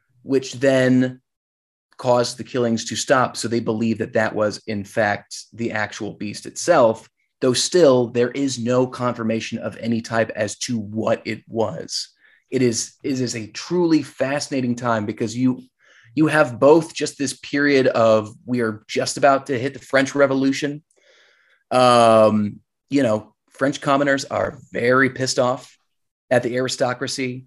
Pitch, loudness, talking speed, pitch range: 125 Hz, -20 LUFS, 155 wpm, 115-135 Hz